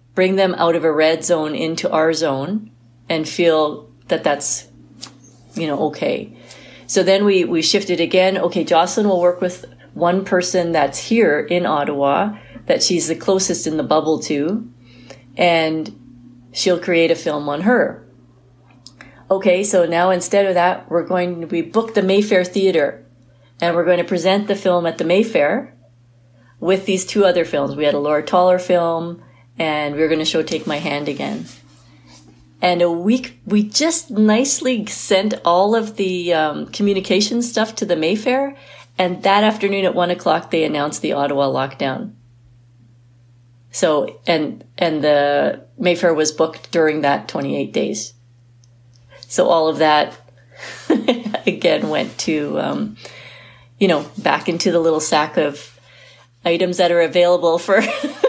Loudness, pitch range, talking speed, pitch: -17 LUFS, 135-185 Hz, 155 wpm, 170 Hz